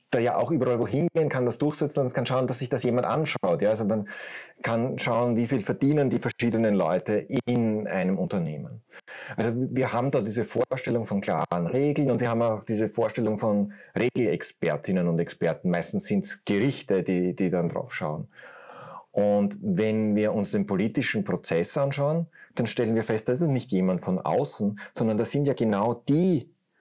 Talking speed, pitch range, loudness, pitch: 185 wpm, 105-135 Hz, -26 LUFS, 120 Hz